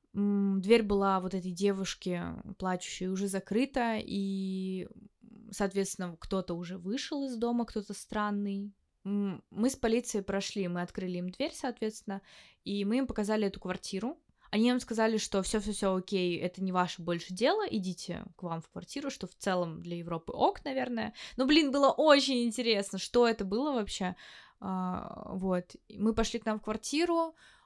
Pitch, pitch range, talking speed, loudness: 205 Hz, 190-230 Hz, 160 wpm, -32 LUFS